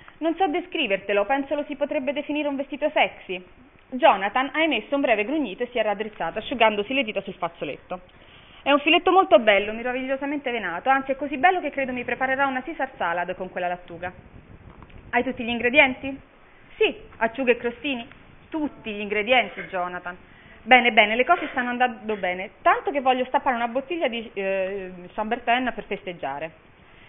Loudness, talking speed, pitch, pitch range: -23 LUFS, 170 wpm, 245 Hz, 205-285 Hz